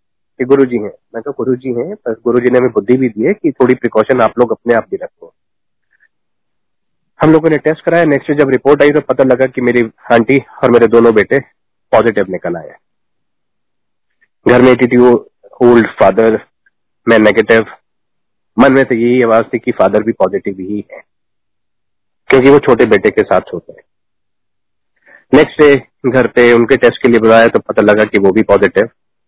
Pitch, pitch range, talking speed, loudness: 125 Hz, 115-140 Hz, 170 wpm, -10 LUFS